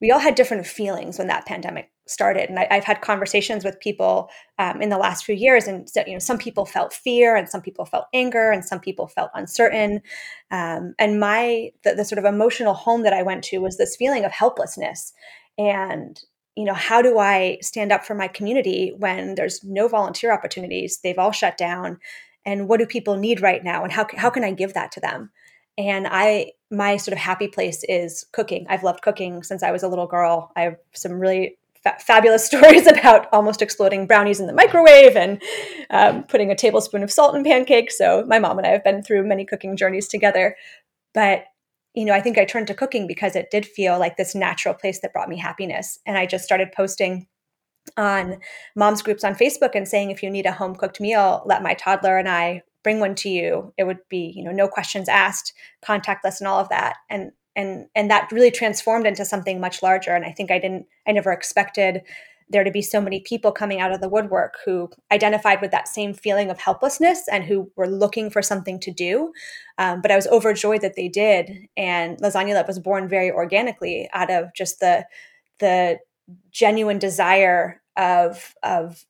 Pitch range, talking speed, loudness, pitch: 190-220 Hz, 210 wpm, -19 LUFS, 200 Hz